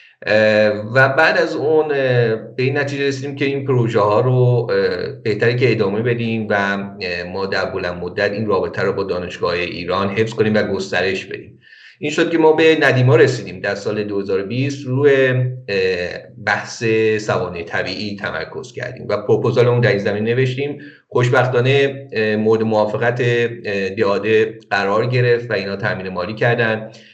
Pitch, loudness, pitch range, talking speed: 115 Hz, -17 LUFS, 100-130 Hz, 150 wpm